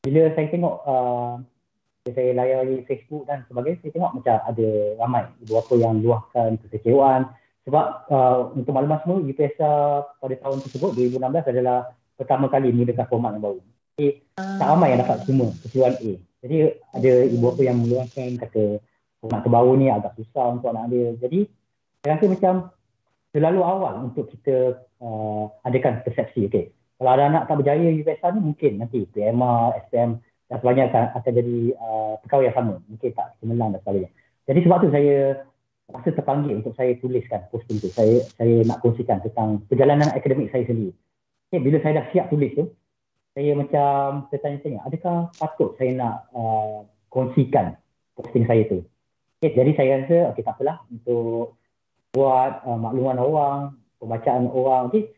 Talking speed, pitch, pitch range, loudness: 165 wpm, 130 Hz, 115-145 Hz, -22 LUFS